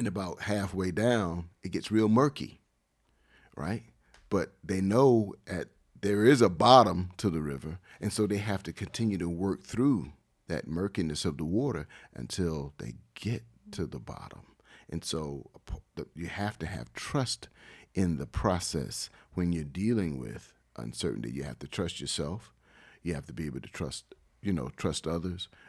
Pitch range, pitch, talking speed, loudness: 85-105 Hz, 95 Hz, 165 wpm, -31 LUFS